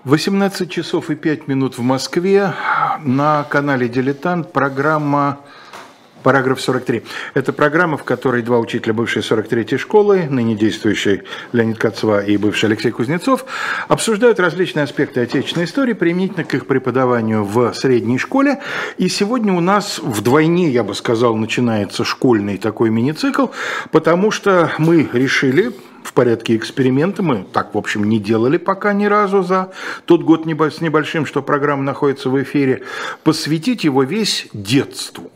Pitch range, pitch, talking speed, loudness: 125-180 Hz, 145 Hz, 145 wpm, -16 LUFS